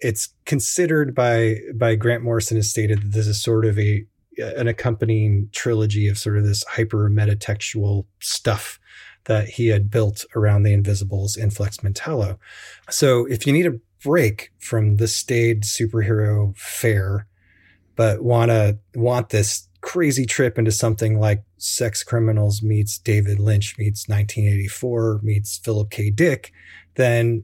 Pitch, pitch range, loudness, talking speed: 110 Hz, 105-115 Hz, -20 LUFS, 145 wpm